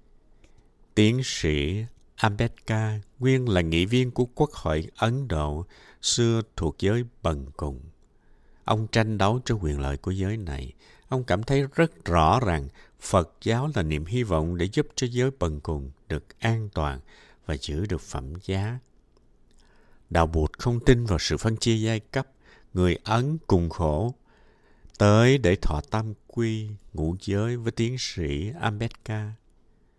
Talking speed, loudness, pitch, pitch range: 155 wpm, -26 LUFS, 105 Hz, 80-120 Hz